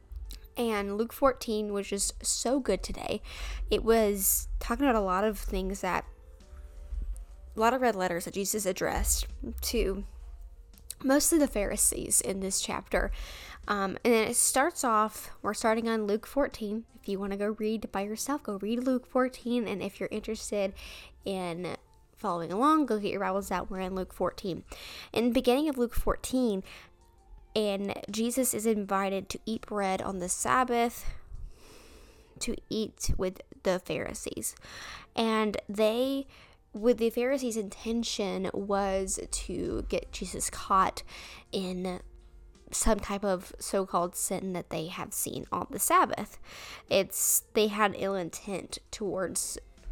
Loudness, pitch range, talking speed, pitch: -30 LUFS, 190-230 Hz, 145 wpm, 210 Hz